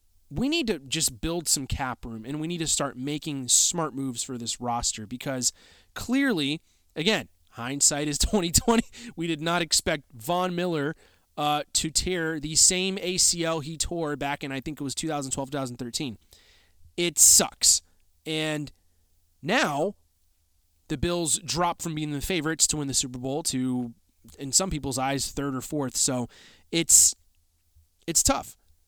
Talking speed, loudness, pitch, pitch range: 155 wpm, -24 LUFS, 140 Hz, 115-160 Hz